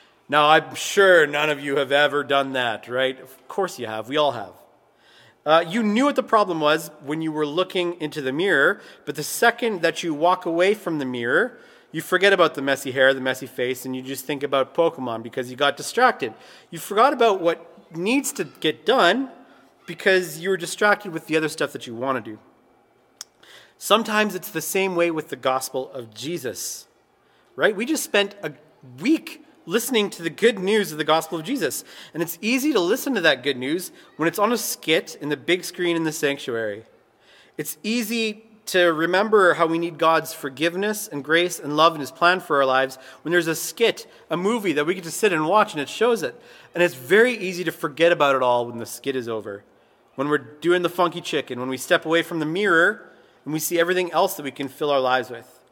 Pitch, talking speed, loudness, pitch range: 165 Hz, 220 wpm, -22 LUFS, 145-195 Hz